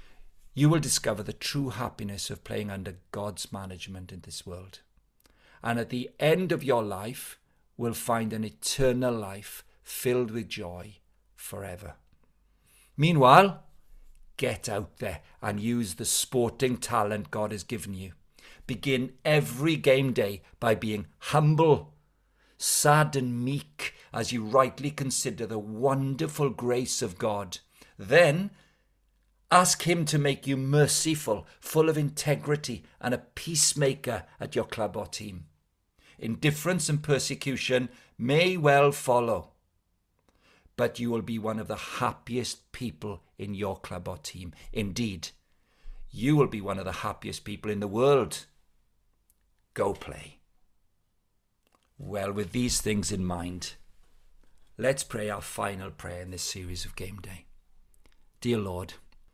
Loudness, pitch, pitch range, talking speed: -28 LUFS, 110 Hz, 95-135 Hz, 135 wpm